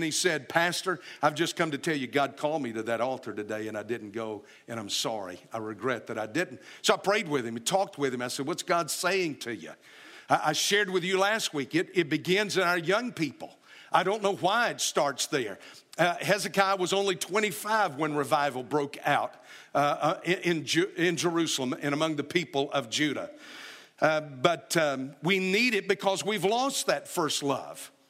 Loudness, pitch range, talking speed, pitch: -28 LUFS, 140-195 Hz, 190 wpm, 165 Hz